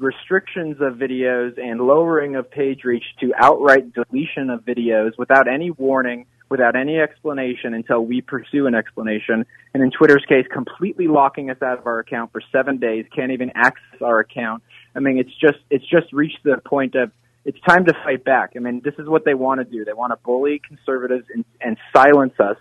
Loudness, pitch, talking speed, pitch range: -18 LUFS, 130 Hz, 200 wpm, 125-145 Hz